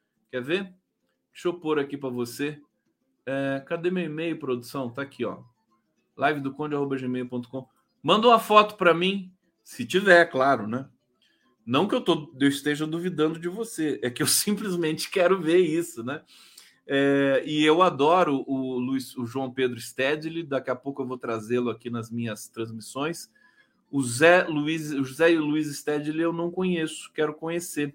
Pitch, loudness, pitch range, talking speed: 150 Hz, -25 LUFS, 130-170 Hz, 170 wpm